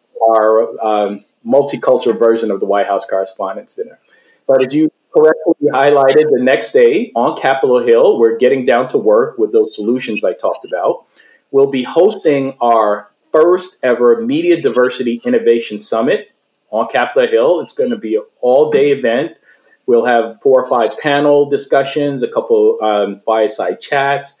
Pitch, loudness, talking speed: 145 Hz, -13 LUFS, 160 wpm